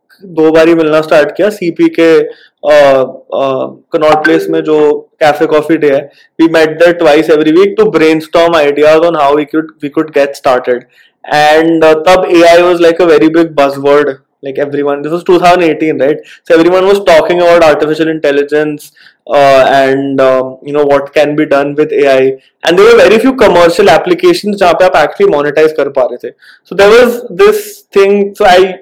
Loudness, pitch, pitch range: -7 LUFS, 155 Hz, 145-180 Hz